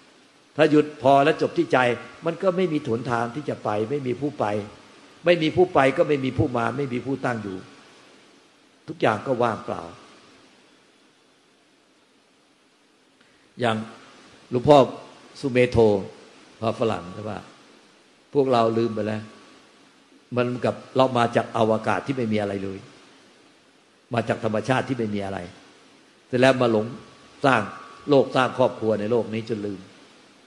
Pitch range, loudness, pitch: 110-135 Hz, -23 LUFS, 120 Hz